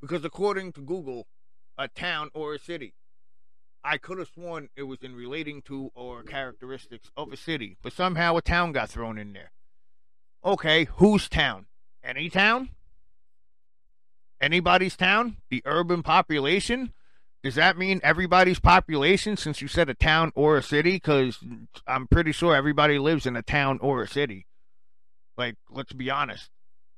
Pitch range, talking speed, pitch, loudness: 105-170 Hz, 155 wpm, 140 Hz, -24 LUFS